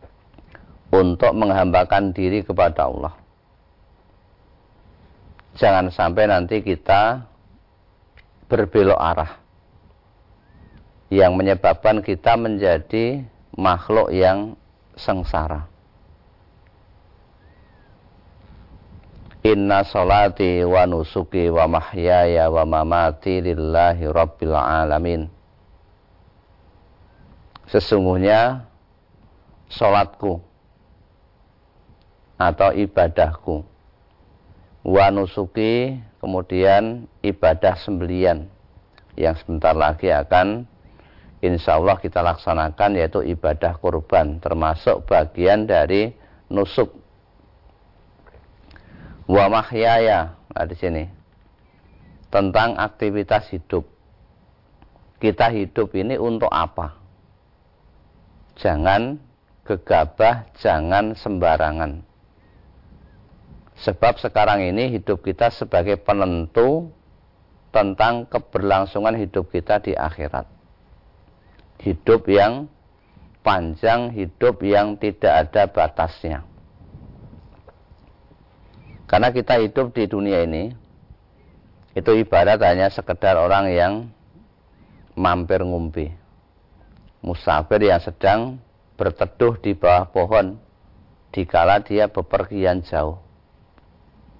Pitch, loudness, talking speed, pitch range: 95 Hz, -19 LUFS, 70 wpm, 85-105 Hz